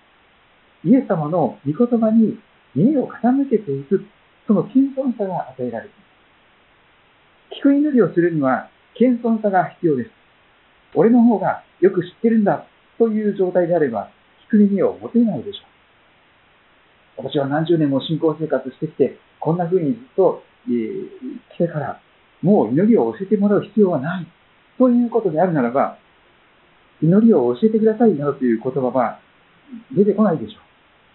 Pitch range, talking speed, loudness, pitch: 155-230 Hz, 310 characters per minute, -18 LUFS, 200 Hz